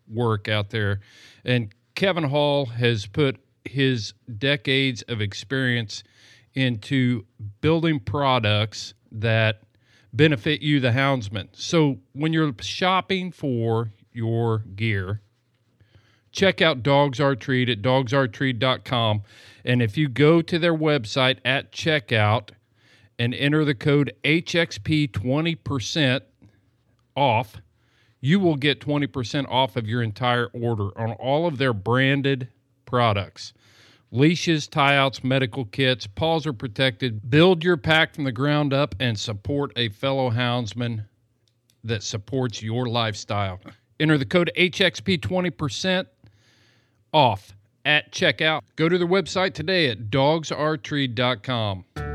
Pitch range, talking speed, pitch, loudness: 115-145 Hz, 115 wpm, 125 Hz, -22 LUFS